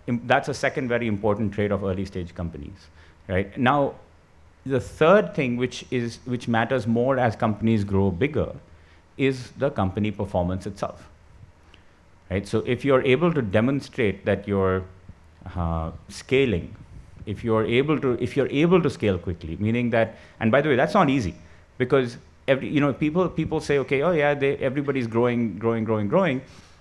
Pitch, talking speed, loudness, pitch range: 110 Hz, 170 wpm, -24 LUFS, 95-130 Hz